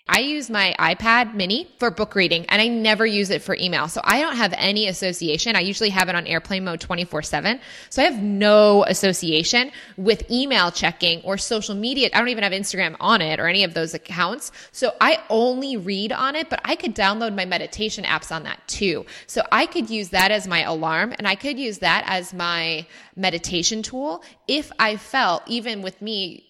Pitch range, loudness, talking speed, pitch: 180-230 Hz, -20 LUFS, 205 wpm, 205 Hz